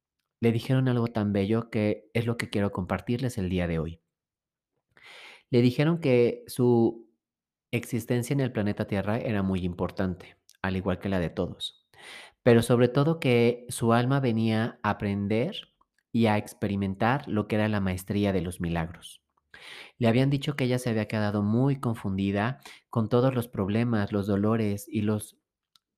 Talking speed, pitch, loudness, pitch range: 165 wpm, 110 Hz, -27 LUFS, 100-120 Hz